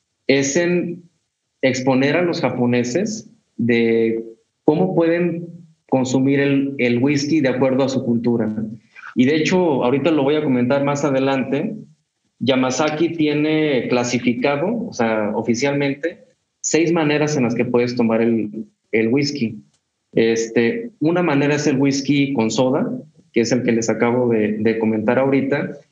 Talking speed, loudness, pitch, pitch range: 145 wpm, -18 LUFS, 135 Hz, 120-150 Hz